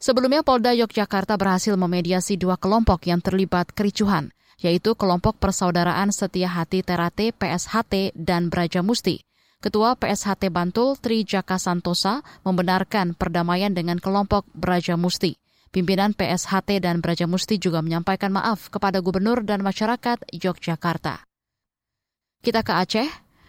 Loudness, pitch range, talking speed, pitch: -22 LUFS, 180-210 Hz, 120 wpm, 190 Hz